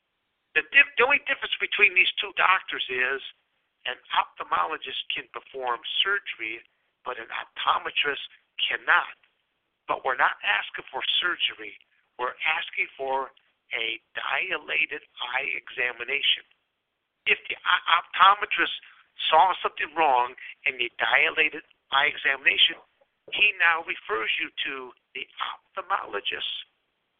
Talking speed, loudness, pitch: 115 wpm, -24 LUFS, 175 Hz